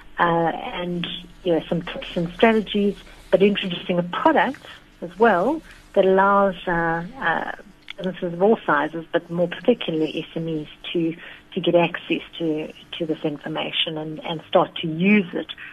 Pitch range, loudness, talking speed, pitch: 165-195 Hz, -22 LUFS, 155 wpm, 175 Hz